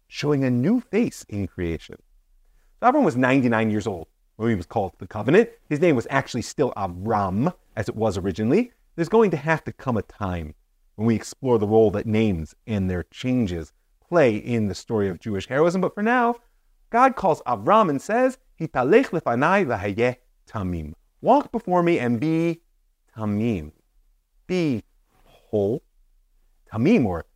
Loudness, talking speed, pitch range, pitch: -23 LUFS, 165 wpm, 100-165 Hz, 120 Hz